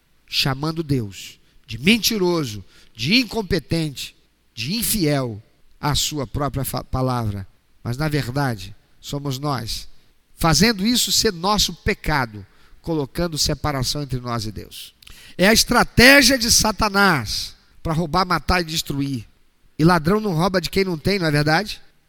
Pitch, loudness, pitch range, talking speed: 150 Hz, -19 LUFS, 125-185 Hz, 135 wpm